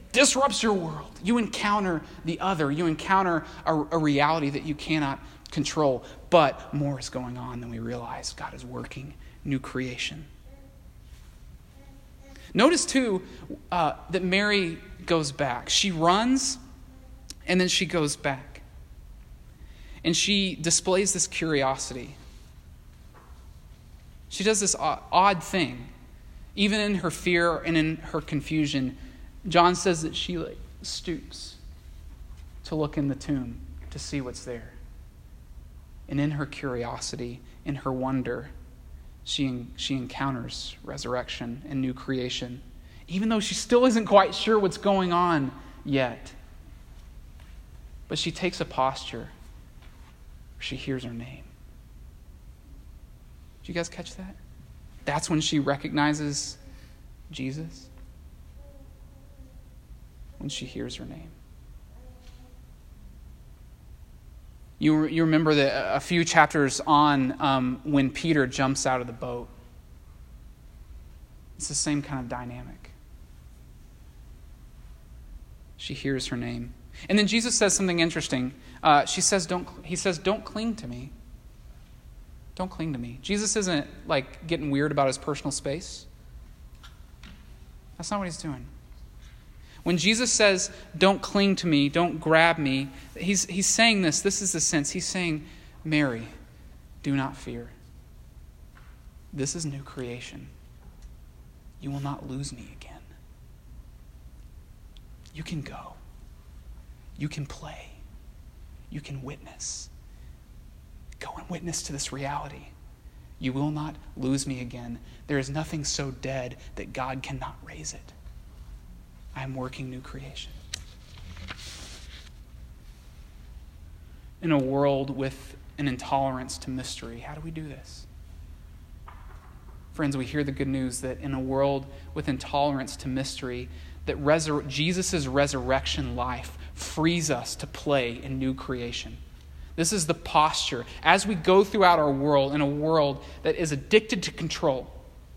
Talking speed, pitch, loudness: 130 wpm, 130 Hz, -26 LUFS